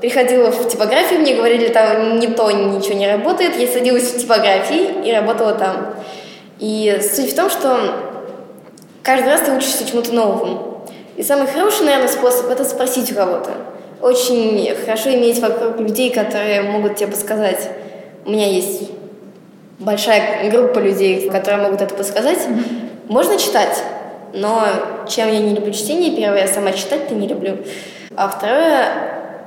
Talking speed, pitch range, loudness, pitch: 150 wpm, 205-250 Hz, -16 LUFS, 220 Hz